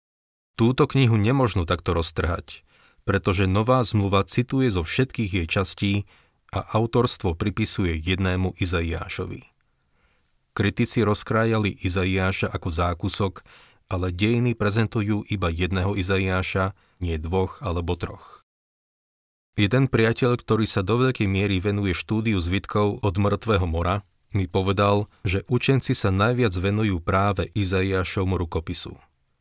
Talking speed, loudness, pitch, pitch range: 115 wpm, -23 LUFS, 100 Hz, 90-110 Hz